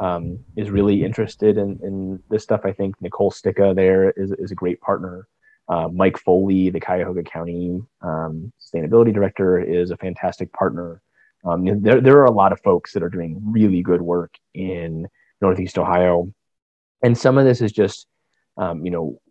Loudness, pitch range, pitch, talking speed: -19 LUFS, 90-105 Hz, 95 Hz, 175 wpm